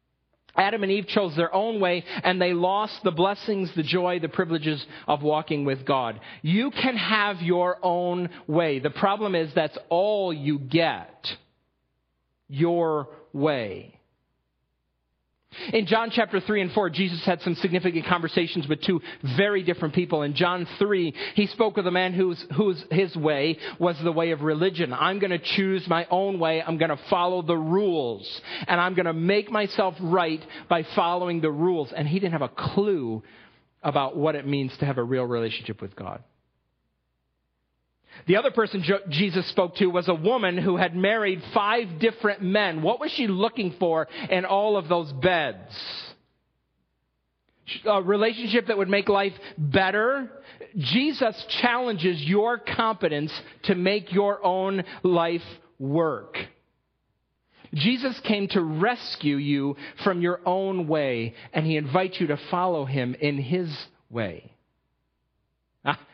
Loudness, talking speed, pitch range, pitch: -25 LUFS, 155 wpm, 155-195 Hz, 180 Hz